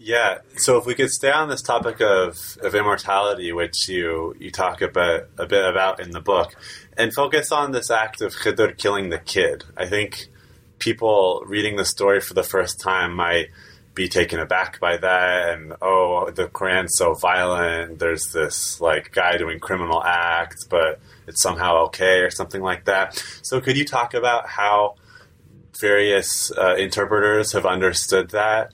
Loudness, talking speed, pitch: -20 LUFS, 170 wpm, 105 Hz